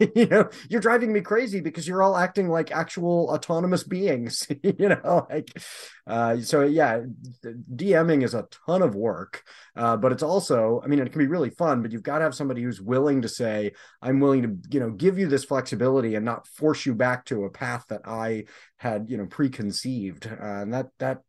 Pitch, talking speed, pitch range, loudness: 135 Hz, 210 wpm, 115-165 Hz, -24 LUFS